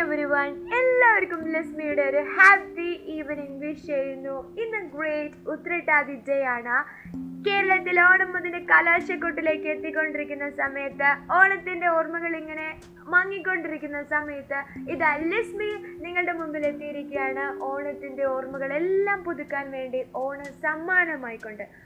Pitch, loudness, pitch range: 310 Hz, -24 LUFS, 280-355 Hz